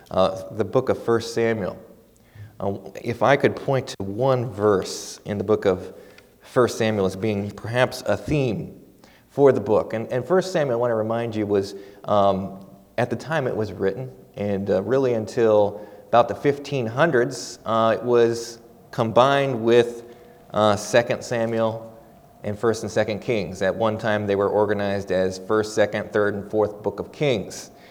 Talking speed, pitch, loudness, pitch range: 170 wpm, 110 Hz, -22 LUFS, 105-120 Hz